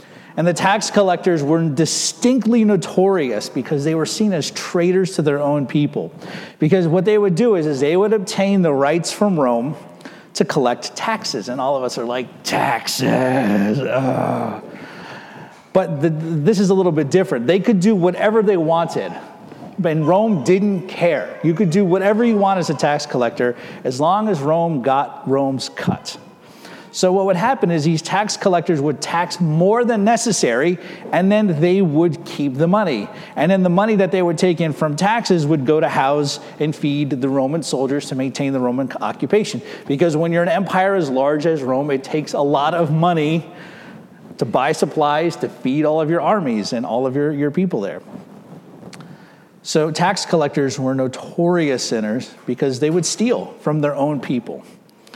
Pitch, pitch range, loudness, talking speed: 170 Hz, 150-195 Hz, -18 LUFS, 180 wpm